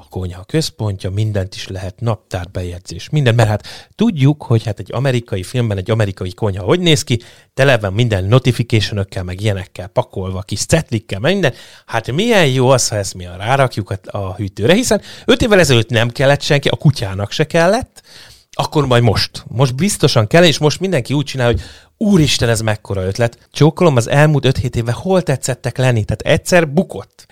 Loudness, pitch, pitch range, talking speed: -15 LUFS, 120 Hz, 100-145 Hz, 180 wpm